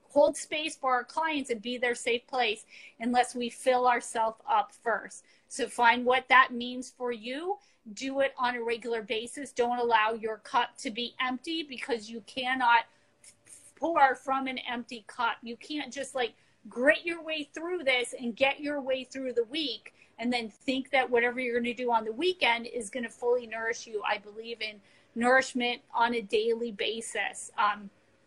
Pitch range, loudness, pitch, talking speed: 235-265 Hz, -29 LUFS, 245 Hz, 185 wpm